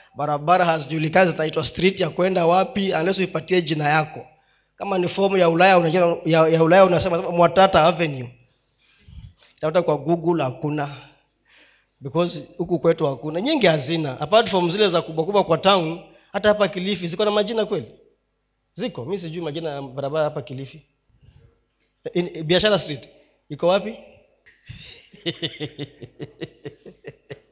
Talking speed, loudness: 130 wpm, -20 LUFS